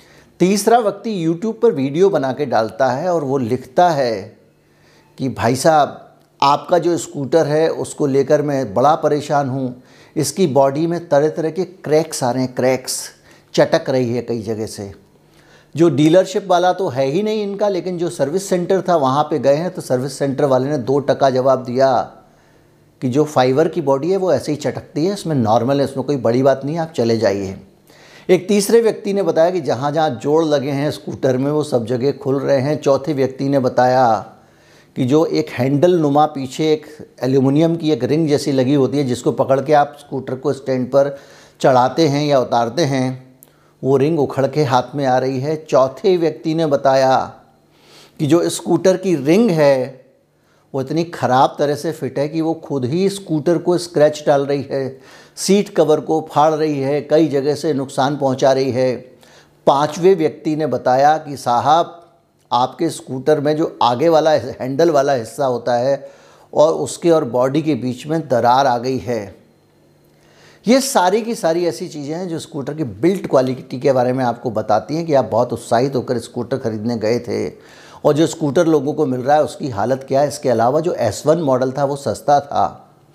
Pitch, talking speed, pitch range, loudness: 145 Hz, 195 wpm, 130-165 Hz, -17 LUFS